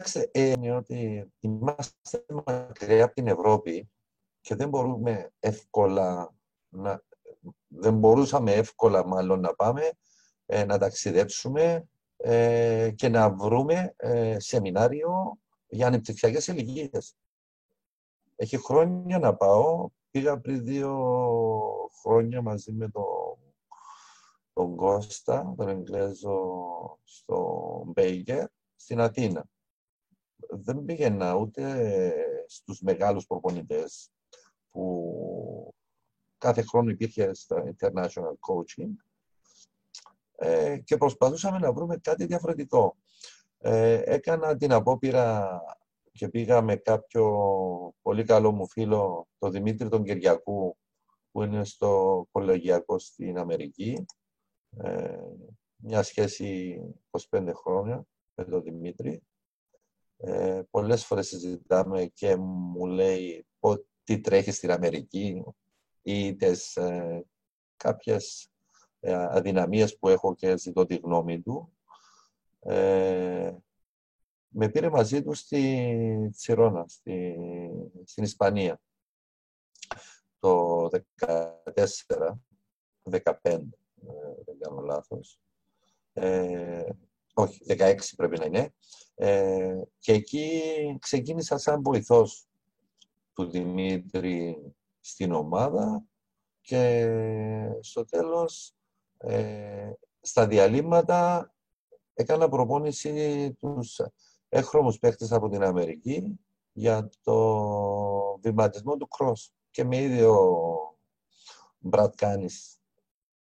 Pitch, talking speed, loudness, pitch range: 115 Hz, 95 wpm, -27 LUFS, 95-150 Hz